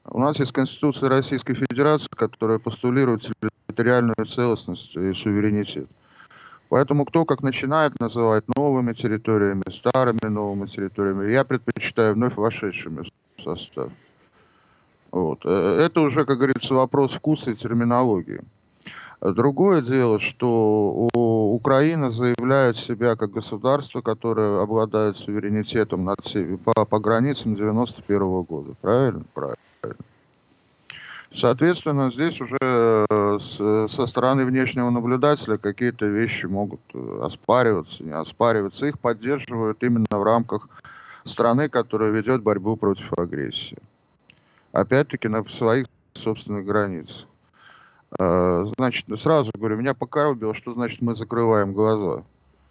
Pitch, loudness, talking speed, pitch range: 115 Hz, -22 LUFS, 105 wpm, 105-130 Hz